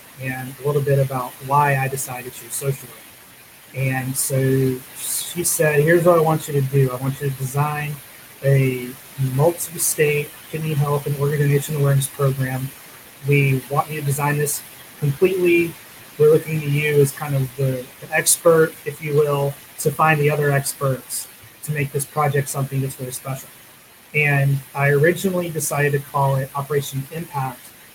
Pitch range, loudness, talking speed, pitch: 135-150 Hz, -20 LUFS, 170 wpm, 140 Hz